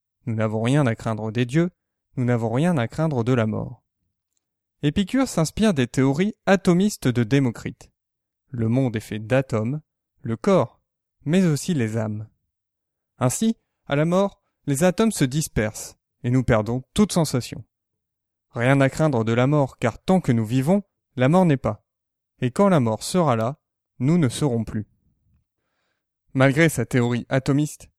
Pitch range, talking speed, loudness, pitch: 110-150 Hz, 160 wpm, -22 LUFS, 125 Hz